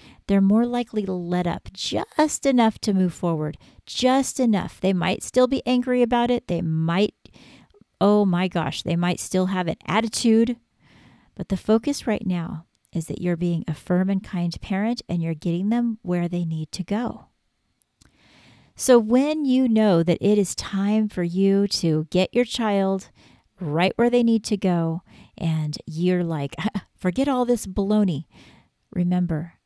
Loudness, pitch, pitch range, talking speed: -23 LUFS, 195 Hz, 175-225 Hz, 165 wpm